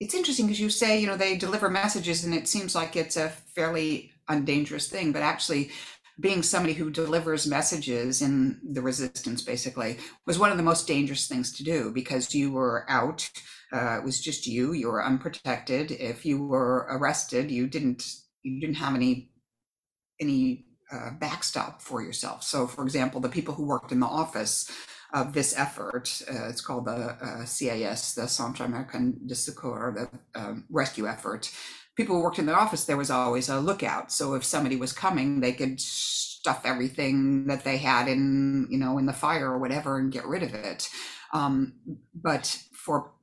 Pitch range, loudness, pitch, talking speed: 130-160 Hz, -28 LUFS, 135 Hz, 185 wpm